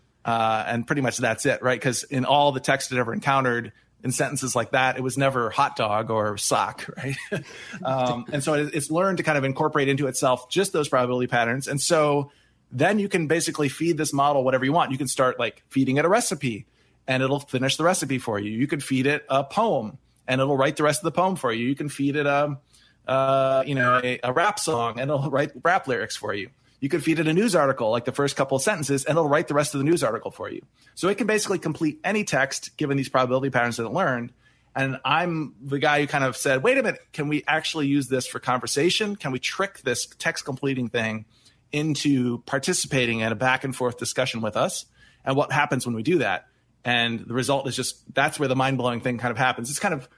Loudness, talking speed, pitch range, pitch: -24 LUFS, 240 wpm, 125-150 Hz, 135 Hz